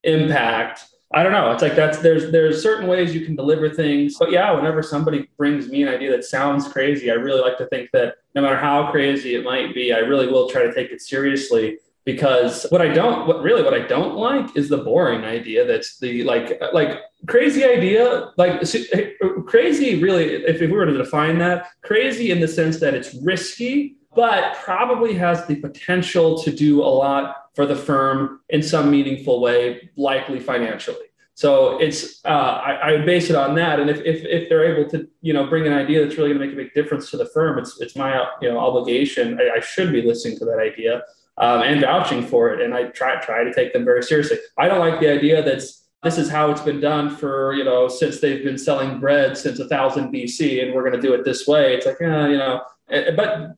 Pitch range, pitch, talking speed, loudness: 140-220 Hz, 155 Hz, 225 wpm, -19 LUFS